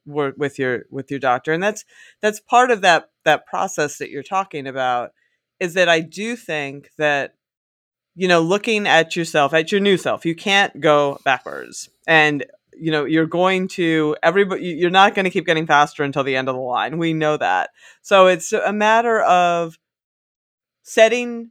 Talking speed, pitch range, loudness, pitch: 185 wpm, 145-195 Hz, -18 LUFS, 165 Hz